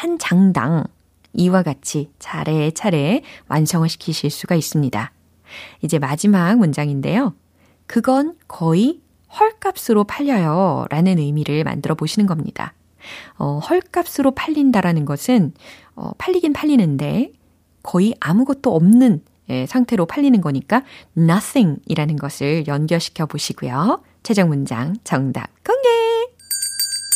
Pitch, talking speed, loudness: 190 Hz, 265 characters per minute, -18 LUFS